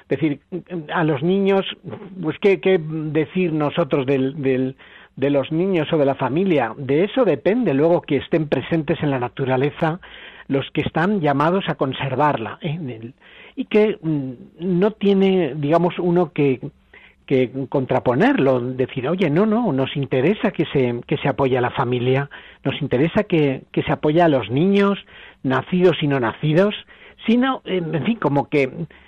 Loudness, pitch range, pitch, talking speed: -20 LUFS, 135-180 Hz, 155 Hz, 160 wpm